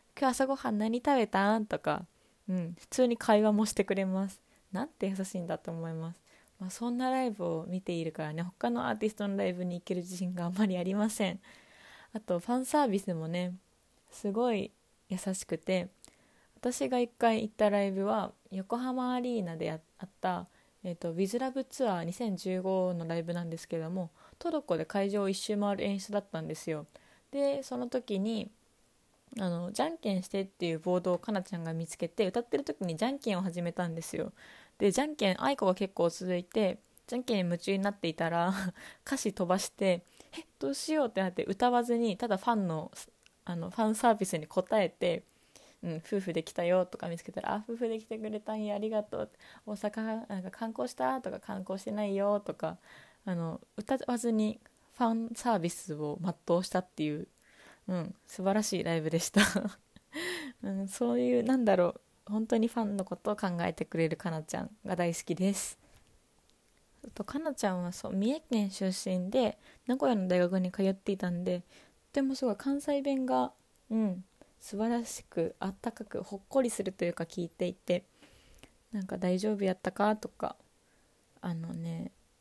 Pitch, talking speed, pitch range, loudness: 195 Hz, 355 characters per minute, 180-230 Hz, -33 LUFS